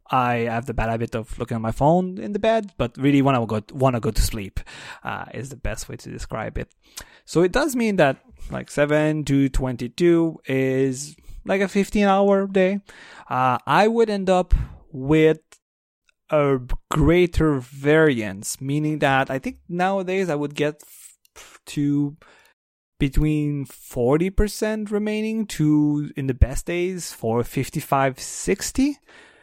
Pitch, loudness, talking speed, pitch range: 150 Hz, -22 LUFS, 155 wpm, 130-190 Hz